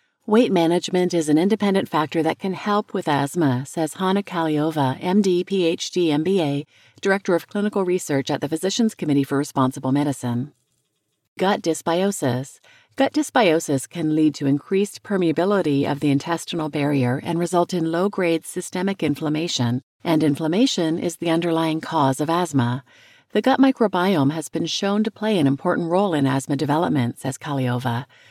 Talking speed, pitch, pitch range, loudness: 150 wpm, 165 Hz, 145-190 Hz, -21 LUFS